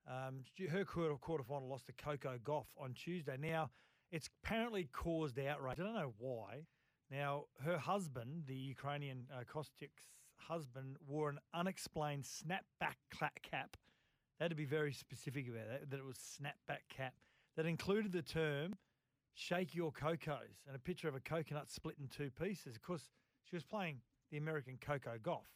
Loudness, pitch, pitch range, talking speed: -45 LUFS, 145 Hz, 135-165 Hz, 165 wpm